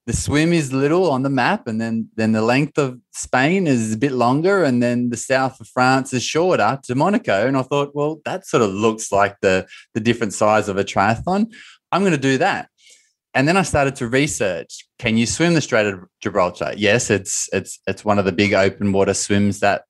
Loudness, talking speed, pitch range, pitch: -19 LUFS, 225 wpm, 105-145 Hz, 120 Hz